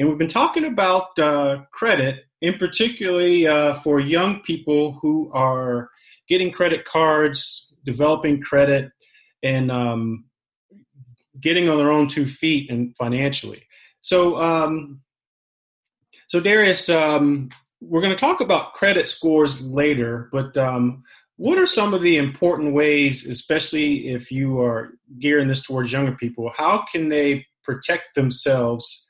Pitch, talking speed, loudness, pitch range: 145 Hz, 135 wpm, -20 LUFS, 130-165 Hz